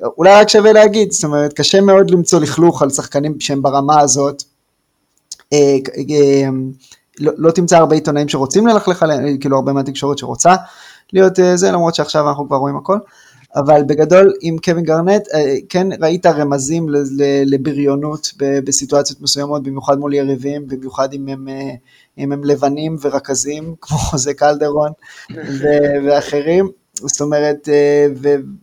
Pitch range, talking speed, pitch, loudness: 140-165 Hz, 125 wpm, 145 Hz, -13 LUFS